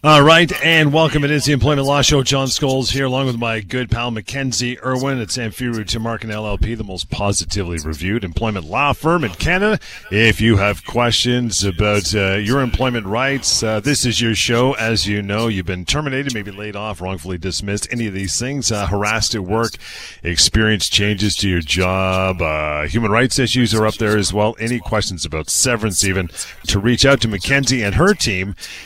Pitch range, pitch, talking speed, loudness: 100-130 Hz, 115 Hz, 200 wpm, -17 LUFS